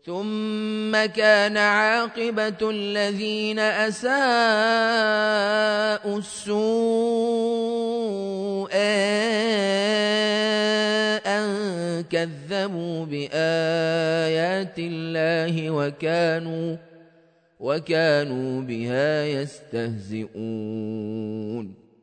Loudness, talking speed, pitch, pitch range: -23 LUFS, 40 wpm, 195 Hz, 160-215 Hz